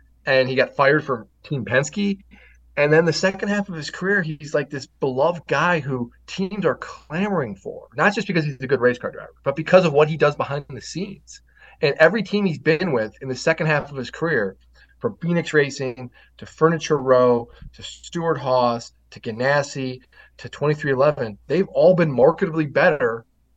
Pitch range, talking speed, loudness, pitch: 130-170 Hz, 190 wpm, -21 LUFS, 150 Hz